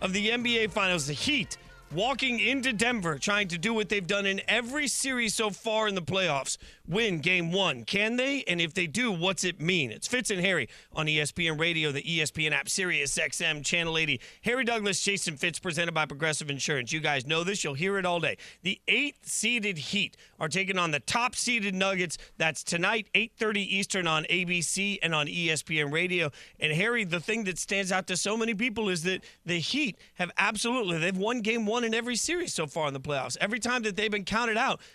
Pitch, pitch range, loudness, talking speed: 190 Hz, 165-220 Hz, -28 LUFS, 210 wpm